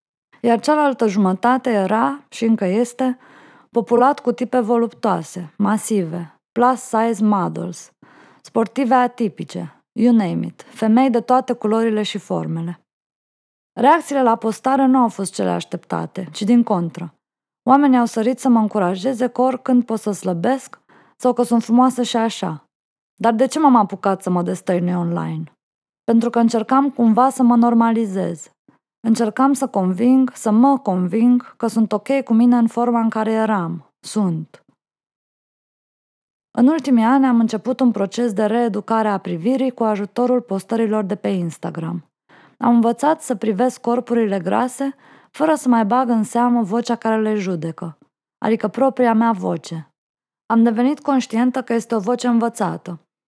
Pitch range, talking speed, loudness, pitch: 200-250 Hz, 150 wpm, -18 LUFS, 230 Hz